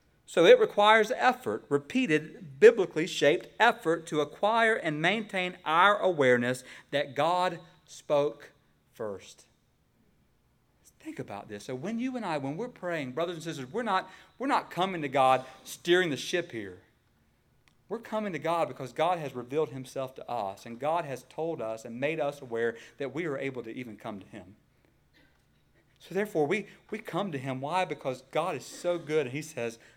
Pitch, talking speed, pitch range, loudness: 155 Hz, 175 wpm, 130-185 Hz, -29 LUFS